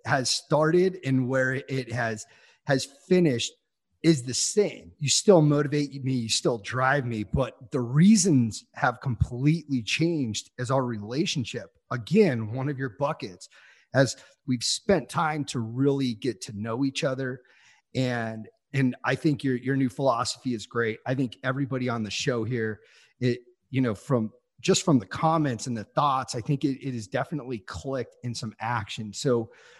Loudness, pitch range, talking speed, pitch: -26 LUFS, 120-145 Hz, 165 wpm, 130 Hz